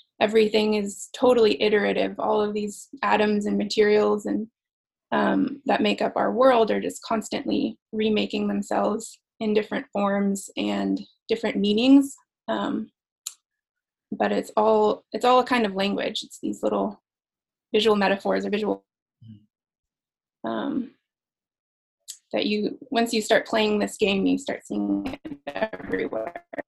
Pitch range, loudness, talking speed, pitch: 205-240 Hz, -24 LUFS, 135 wpm, 215 Hz